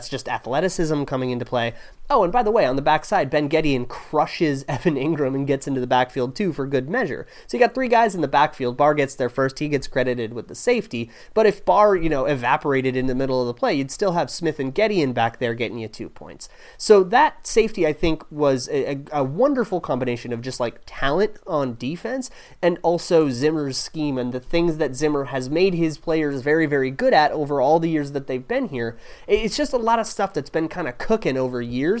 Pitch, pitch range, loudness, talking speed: 145 Hz, 130-175 Hz, -21 LUFS, 235 wpm